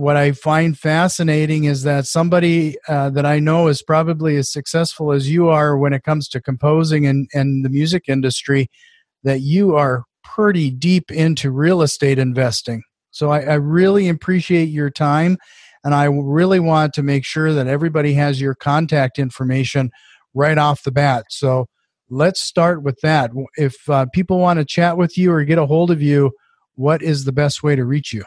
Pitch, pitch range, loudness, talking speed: 150 Hz, 140-165 Hz, -16 LUFS, 185 wpm